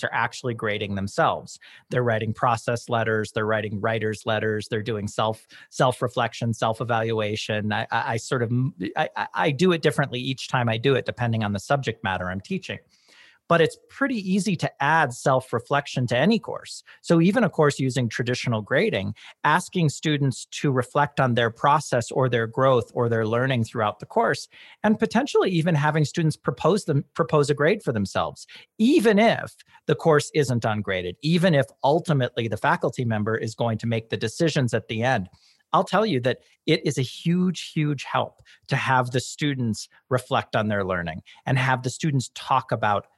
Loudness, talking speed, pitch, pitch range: -24 LUFS, 180 wpm, 130 Hz, 110-155 Hz